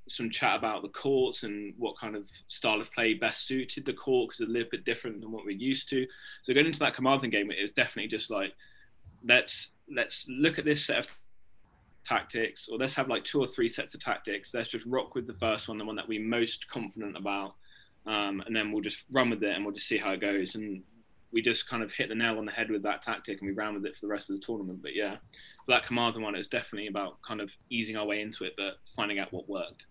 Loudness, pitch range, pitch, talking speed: -31 LUFS, 105-130 Hz, 110 Hz, 260 wpm